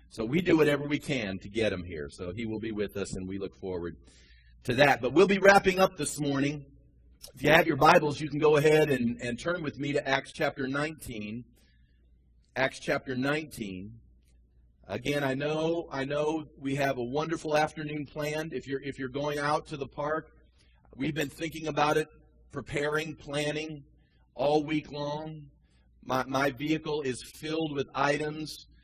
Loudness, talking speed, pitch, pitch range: -29 LUFS, 180 wpm, 140 Hz, 110-150 Hz